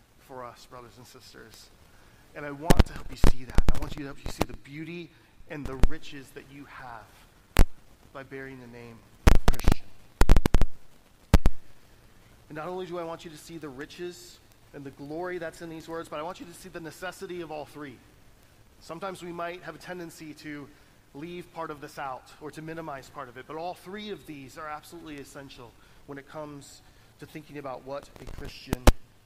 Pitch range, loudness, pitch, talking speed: 120-160 Hz, -33 LUFS, 145 Hz, 205 wpm